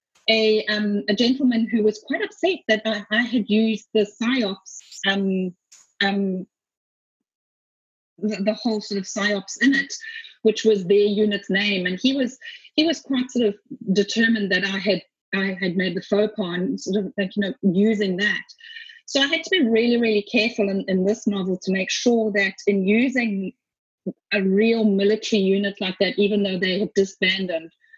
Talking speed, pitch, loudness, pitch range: 180 wpm, 210 Hz, -21 LUFS, 195-230 Hz